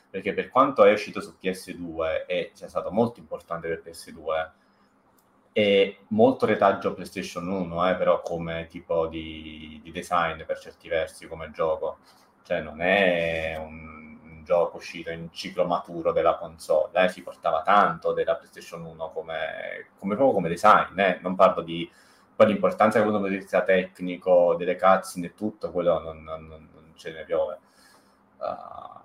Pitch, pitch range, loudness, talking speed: 85 Hz, 80-95 Hz, -25 LUFS, 165 wpm